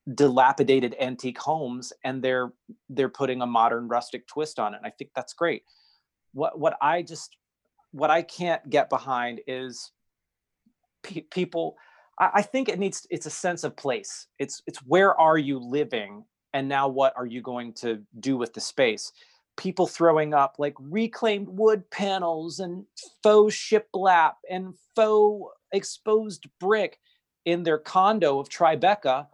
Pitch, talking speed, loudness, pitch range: 160 Hz, 155 wpm, -25 LUFS, 130-195 Hz